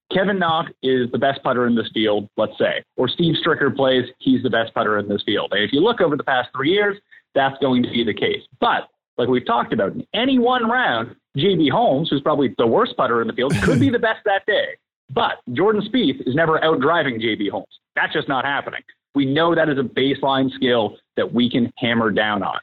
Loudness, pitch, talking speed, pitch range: -19 LUFS, 140 Hz, 235 wpm, 125-200 Hz